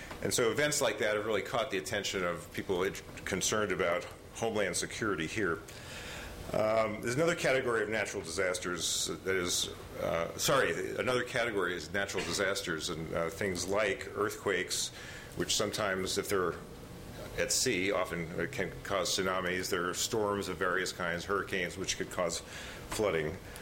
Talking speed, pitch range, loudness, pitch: 150 wpm, 90-110 Hz, -33 LUFS, 100 Hz